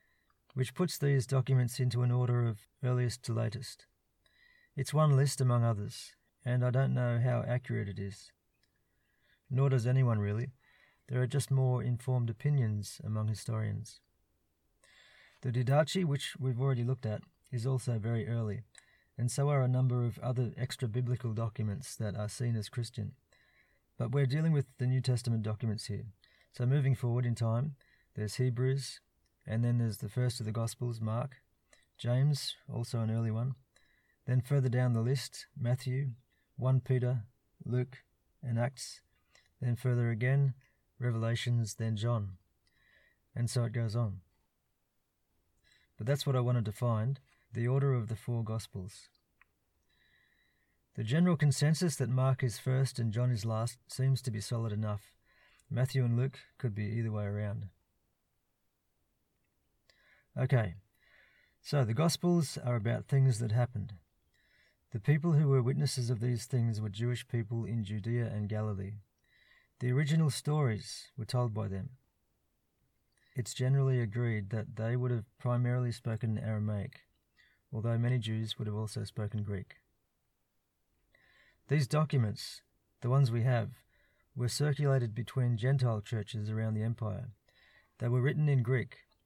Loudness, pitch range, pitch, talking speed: -33 LUFS, 110-130 Hz, 120 Hz, 145 wpm